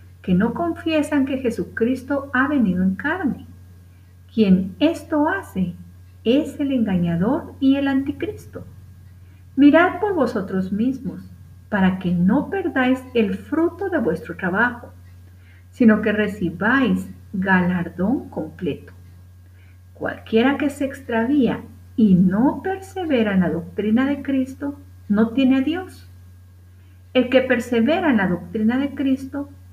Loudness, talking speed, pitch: -20 LUFS, 120 wpm, 220 Hz